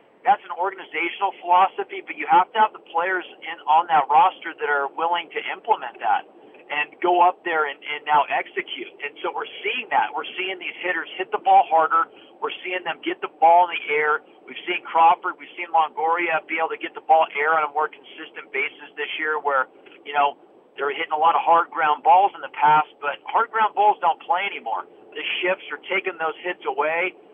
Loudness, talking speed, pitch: -22 LUFS, 215 wpm, 180 Hz